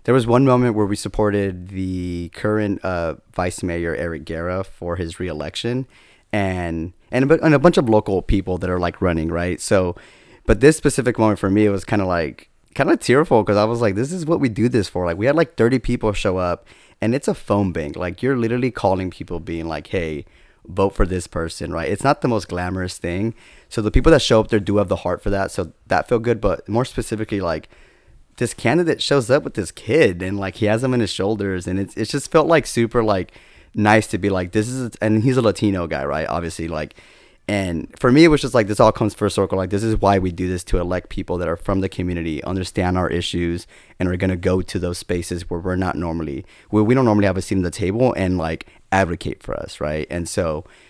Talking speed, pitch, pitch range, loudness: 245 wpm, 95 Hz, 90-110 Hz, -20 LUFS